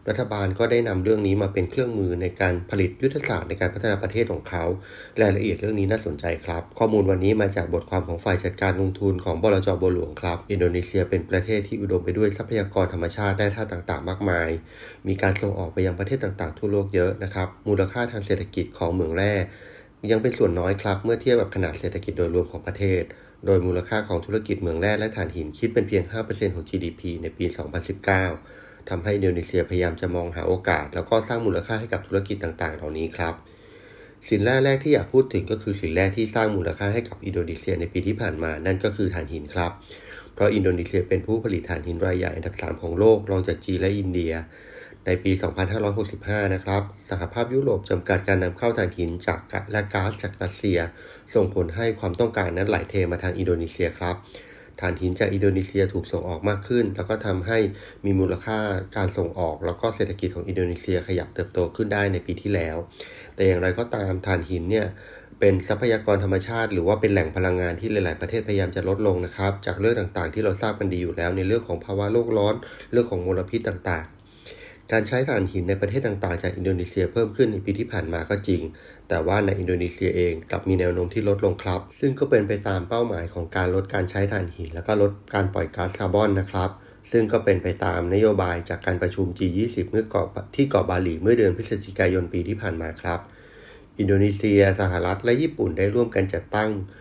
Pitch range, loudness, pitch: 90-105 Hz, -24 LUFS, 95 Hz